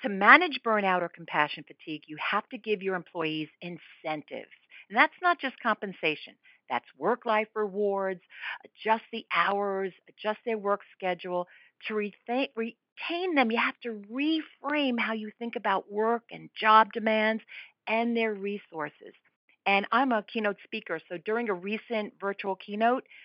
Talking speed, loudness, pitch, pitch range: 150 wpm, -28 LUFS, 215 Hz, 190-235 Hz